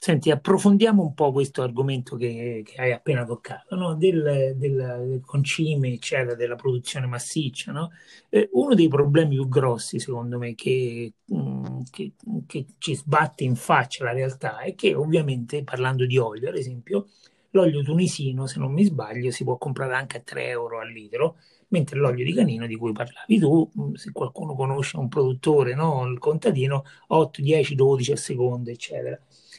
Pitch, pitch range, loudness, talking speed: 135 Hz, 125-155 Hz, -24 LUFS, 170 wpm